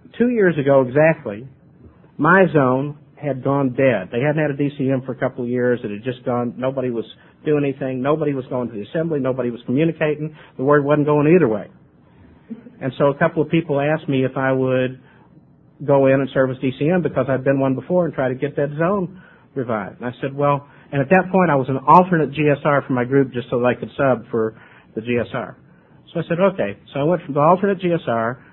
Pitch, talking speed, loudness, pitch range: 140 Hz, 225 wpm, -19 LUFS, 130-155 Hz